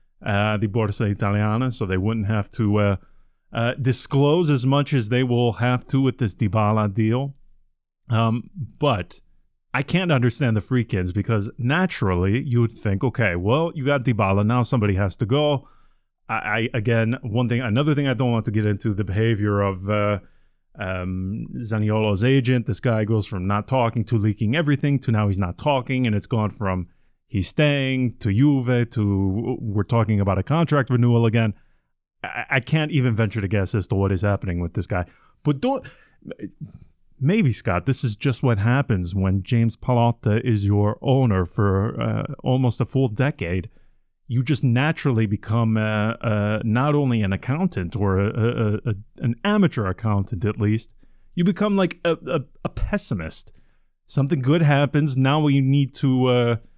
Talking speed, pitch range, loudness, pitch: 175 wpm, 105-135 Hz, -22 LUFS, 115 Hz